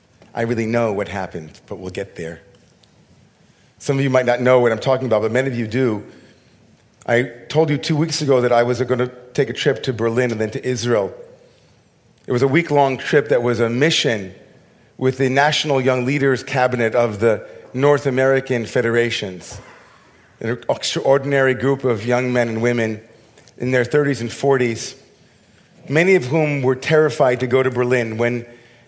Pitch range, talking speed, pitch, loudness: 115-135 Hz, 185 wpm, 125 Hz, -18 LUFS